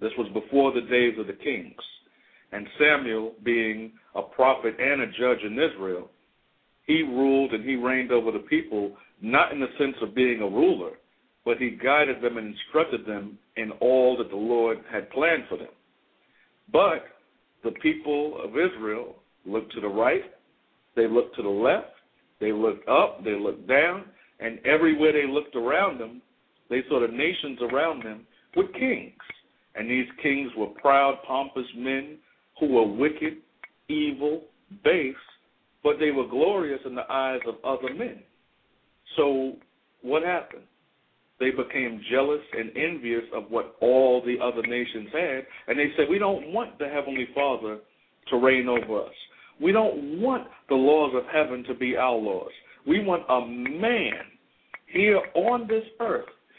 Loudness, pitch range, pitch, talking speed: -25 LUFS, 120-155 Hz, 130 Hz, 160 wpm